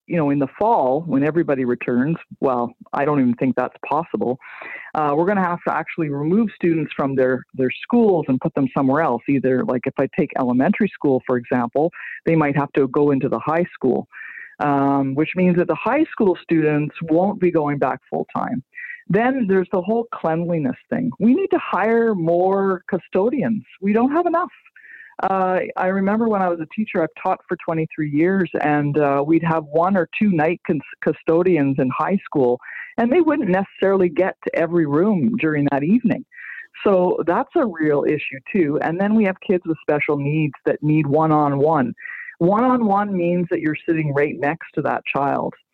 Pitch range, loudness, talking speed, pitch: 145-195 Hz, -20 LUFS, 195 wpm, 165 Hz